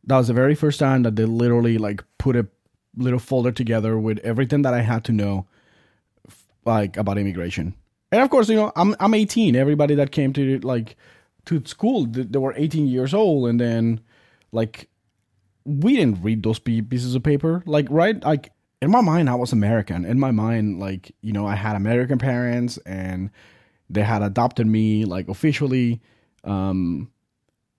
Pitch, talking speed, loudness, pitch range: 120 Hz, 175 wpm, -21 LUFS, 105-140 Hz